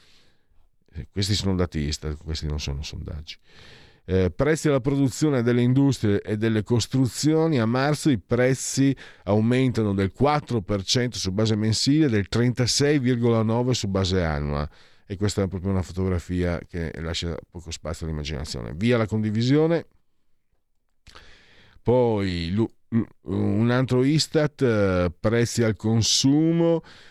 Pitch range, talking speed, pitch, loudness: 90-125 Hz, 120 wpm, 110 Hz, -23 LUFS